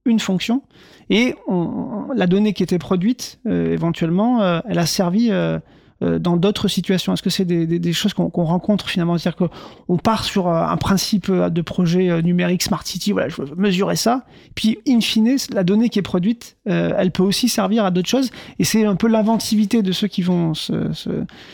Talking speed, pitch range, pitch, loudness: 205 wpm, 175-220 Hz, 195 Hz, -19 LUFS